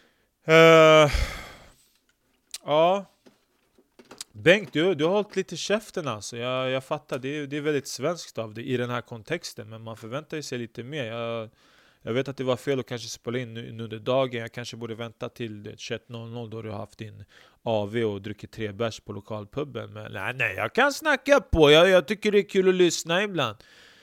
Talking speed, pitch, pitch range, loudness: 195 wpm, 125 Hz, 115-155 Hz, -24 LUFS